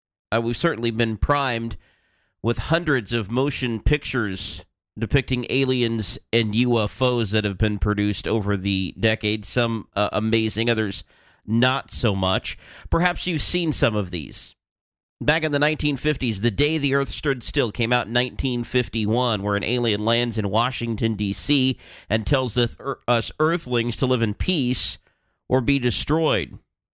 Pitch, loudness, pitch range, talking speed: 120 Hz, -22 LUFS, 105-130 Hz, 145 wpm